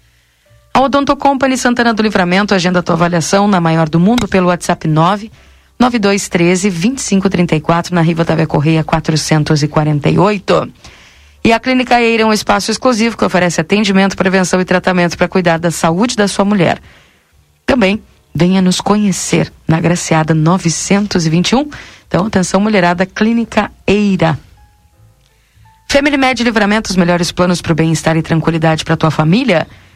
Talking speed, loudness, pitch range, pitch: 140 wpm, -12 LUFS, 160-205 Hz, 180 Hz